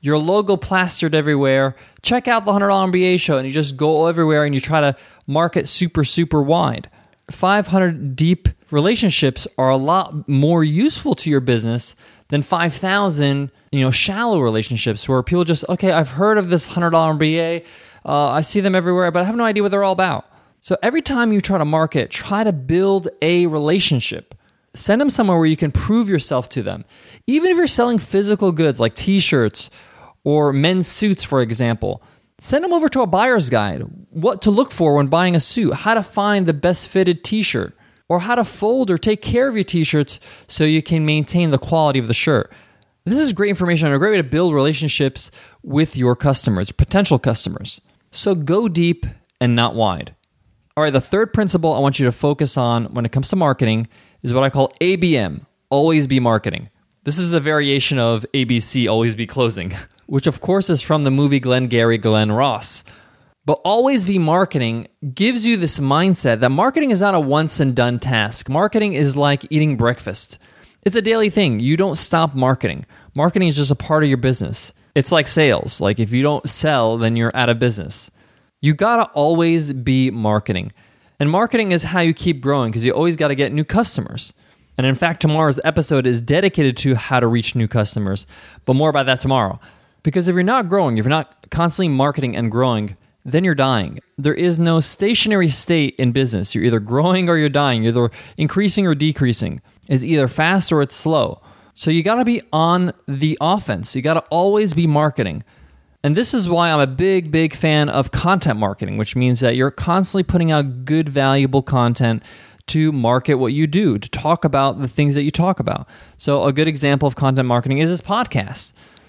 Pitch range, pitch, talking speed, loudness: 130-180 Hz, 150 Hz, 200 wpm, -17 LUFS